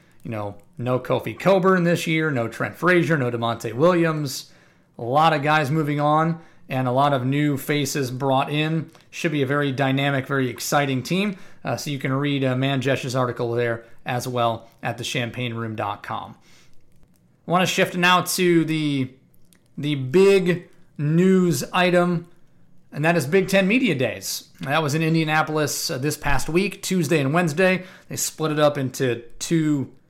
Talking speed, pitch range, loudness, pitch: 165 wpm, 130-170 Hz, -22 LUFS, 150 Hz